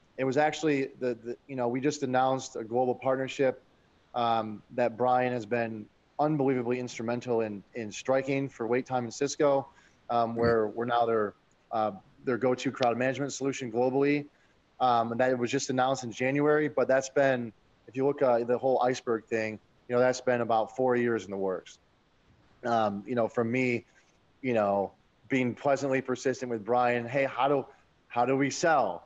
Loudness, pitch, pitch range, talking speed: -29 LUFS, 125 Hz, 115-135 Hz, 185 wpm